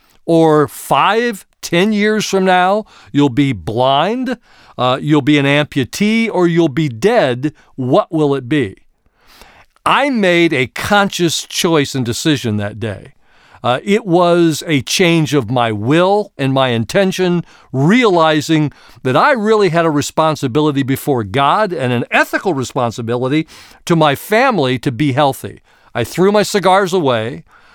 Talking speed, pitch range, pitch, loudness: 145 wpm, 135-185 Hz, 155 Hz, -14 LUFS